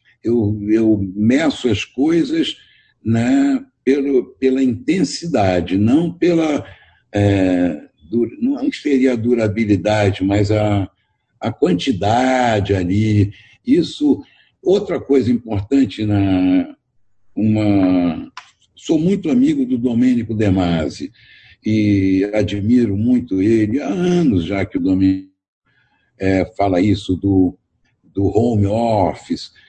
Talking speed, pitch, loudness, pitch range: 105 wpm, 110 Hz, -17 LUFS, 100-135 Hz